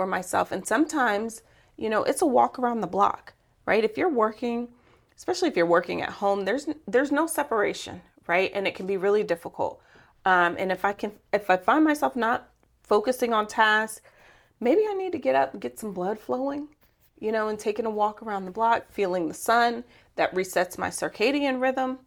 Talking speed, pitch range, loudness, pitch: 200 wpm, 200-260 Hz, -25 LUFS, 220 Hz